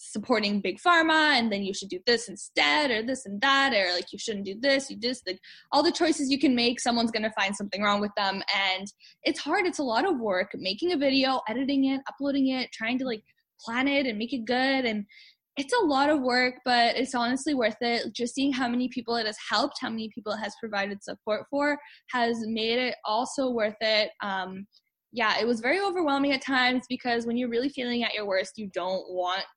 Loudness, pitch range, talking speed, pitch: -26 LUFS, 210-270 Hz, 225 wpm, 240 Hz